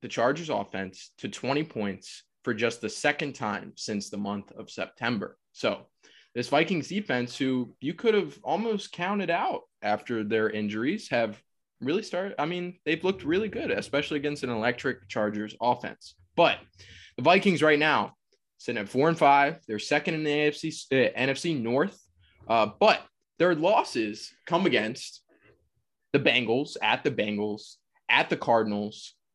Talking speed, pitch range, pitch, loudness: 155 wpm, 105-155 Hz, 130 Hz, -27 LUFS